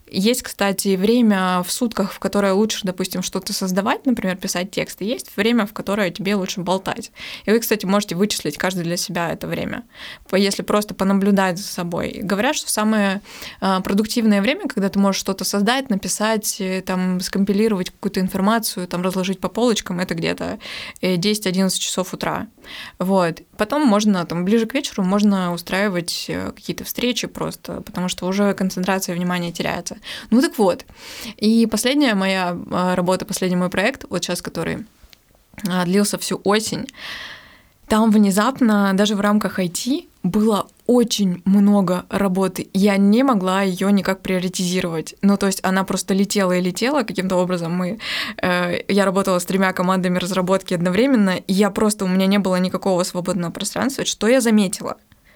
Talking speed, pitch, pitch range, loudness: 155 wpm, 195 Hz, 185-215 Hz, -20 LUFS